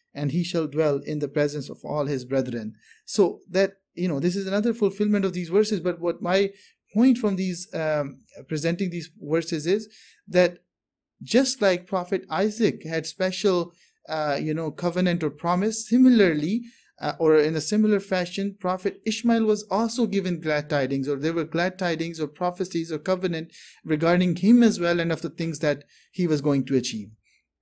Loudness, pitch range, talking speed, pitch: -24 LUFS, 155-195 Hz, 180 wpm, 175 Hz